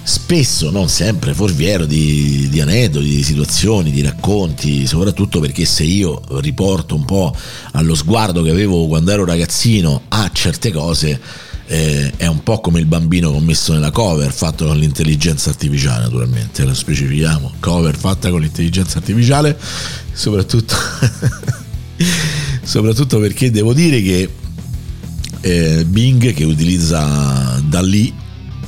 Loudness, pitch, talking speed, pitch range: -14 LUFS, 85 Hz, 135 wpm, 75-110 Hz